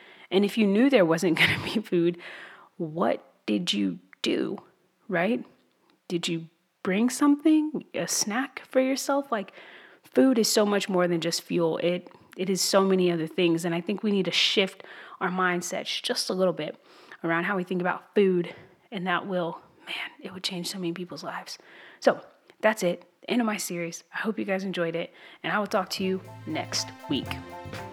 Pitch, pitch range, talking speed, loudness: 185 Hz, 170-205 Hz, 195 wpm, -27 LUFS